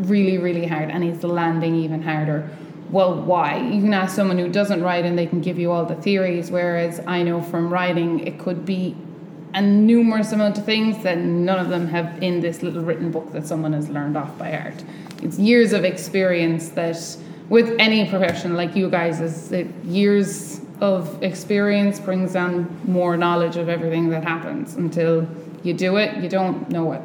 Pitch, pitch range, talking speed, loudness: 175 Hz, 165-190 Hz, 195 wpm, -21 LUFS